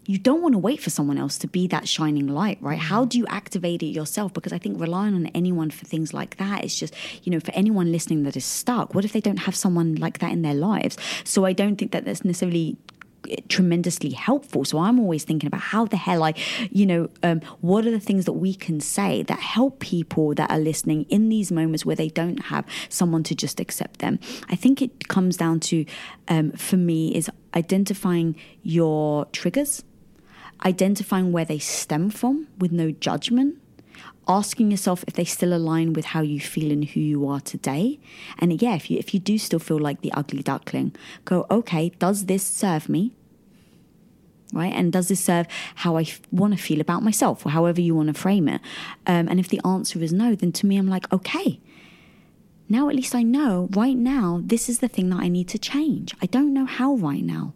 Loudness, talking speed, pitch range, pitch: -23 LUFS, 215 wpm, 165-210 Hz, 185 Hz